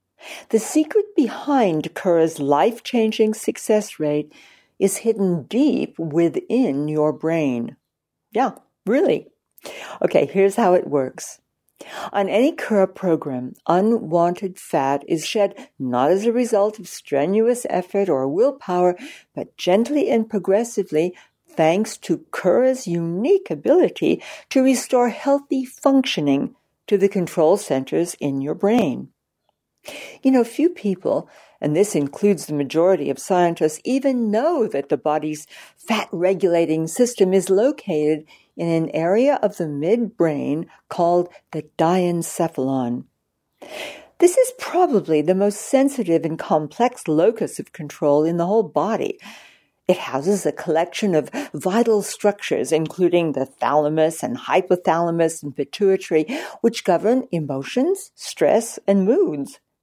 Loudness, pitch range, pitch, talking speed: -20 LUFS, 155-225 Hz, 185 Hz, 125 wpm